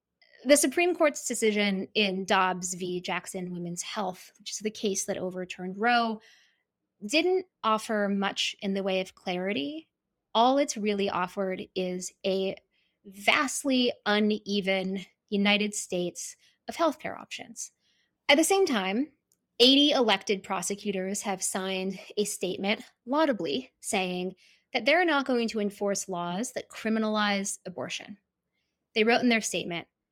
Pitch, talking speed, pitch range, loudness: 205 Hz, 130 wpm, 190-240 Hz, -28 LUFS